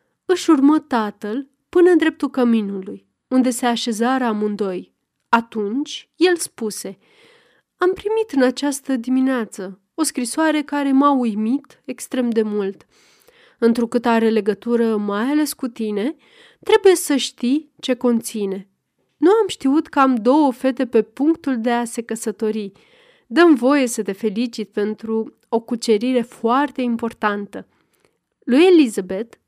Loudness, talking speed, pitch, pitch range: -19 LUFS, 130 wpm, 255 Hz, 225-290 Hz